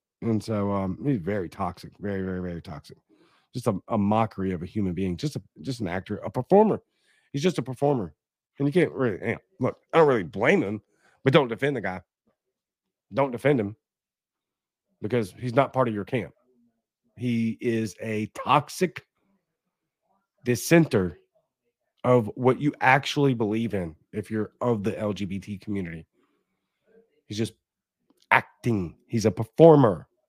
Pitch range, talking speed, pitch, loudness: 105-140 Hz, 155 wpm, 115 Hz, -25 LUFS